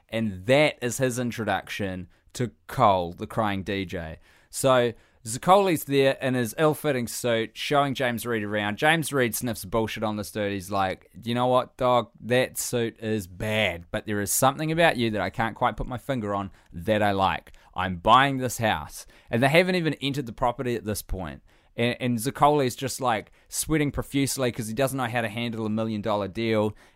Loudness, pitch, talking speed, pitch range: -25 LUFS, 115 Hz, 190 wpm, 105-130 Hz